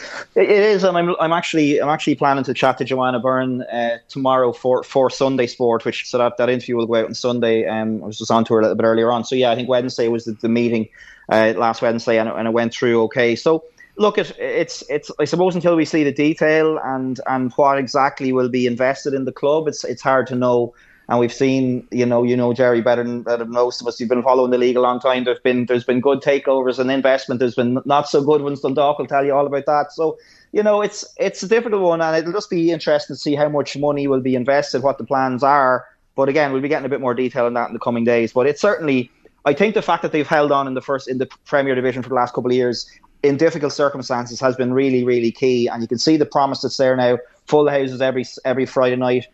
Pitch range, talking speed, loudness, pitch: 125-145 Hz, 265 wpm, -18 LUFS, 130 Hz